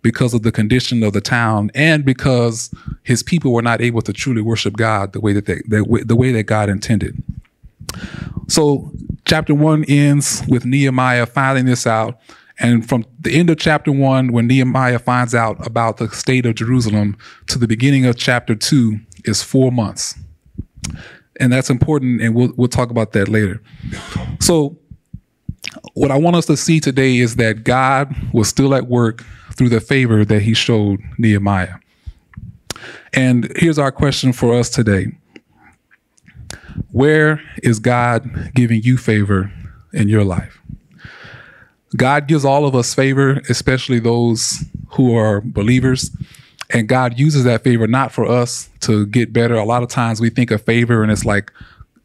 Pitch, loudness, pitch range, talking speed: 120 Hz, -15 LUFS, 110-135 Hz, 165 wpm